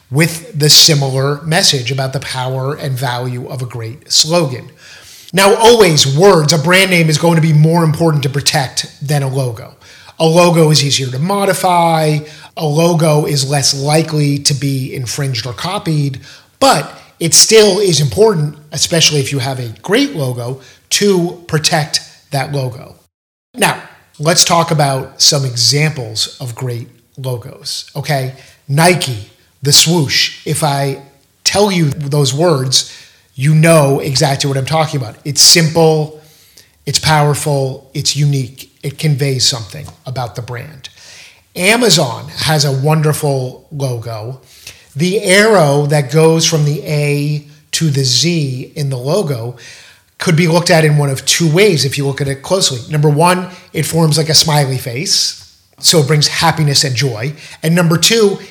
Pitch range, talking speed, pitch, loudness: 135-160 Hz, 155 wpm, 145 Hz, -12 LUFS